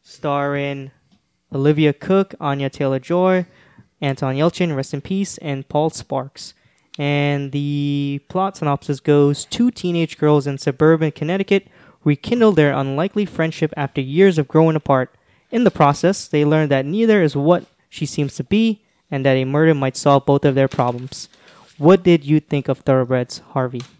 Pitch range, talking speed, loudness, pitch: 140-175 Hz, 160 wpm, -18 LUFS, 150 Hz